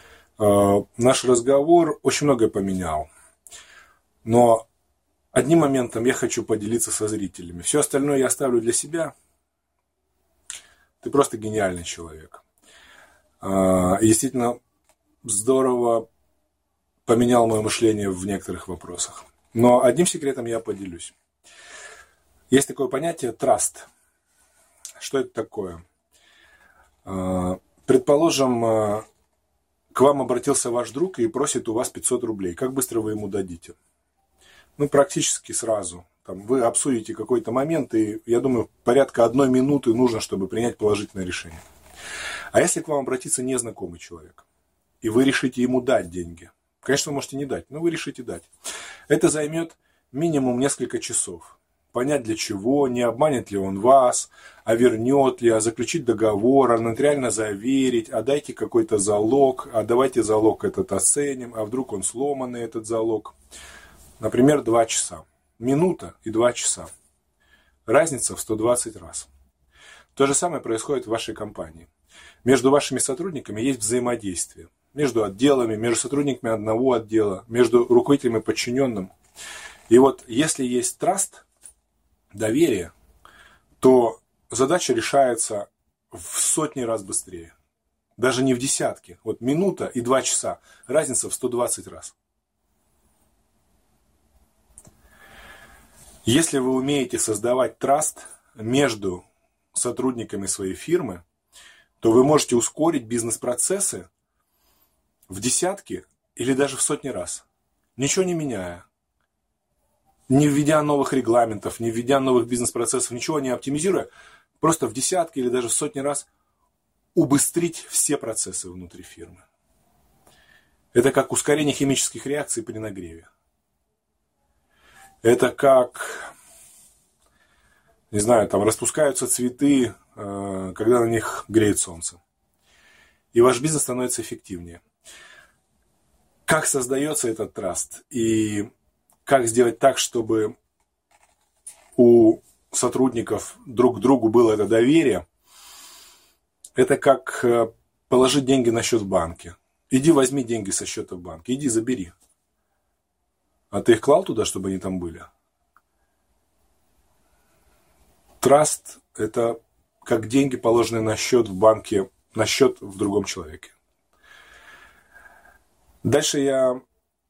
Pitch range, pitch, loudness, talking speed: 100-135 Hz, 120 Hz, -21 LUFS, 120 wpm